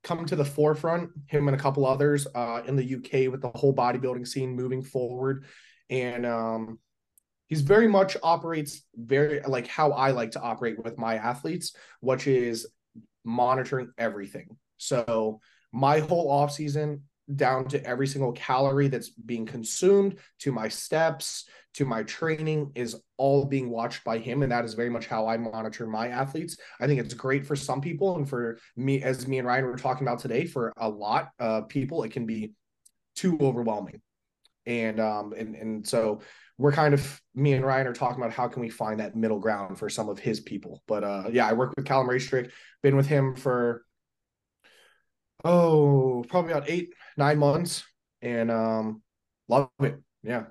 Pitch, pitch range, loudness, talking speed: 130 Hz, 115-145 Hz, -27 LUFS, 180 wpm